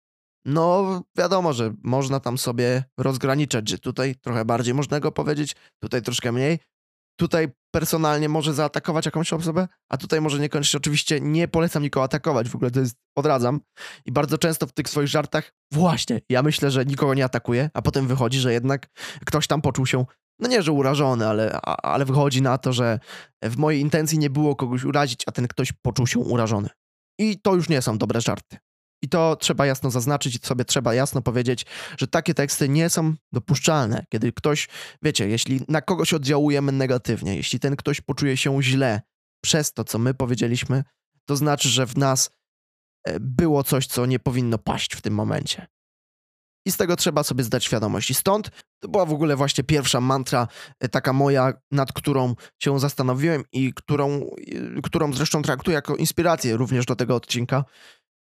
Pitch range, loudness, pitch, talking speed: 125-155 Hz, -22 LUFS, 140 Hz, 180 wpm